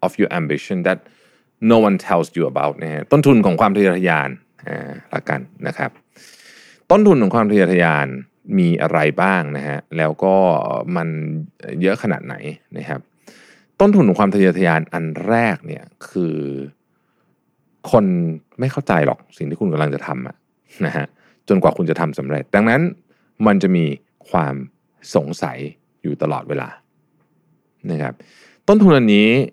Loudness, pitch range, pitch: -17 LUFS, 75-105 Hz, 85 Hz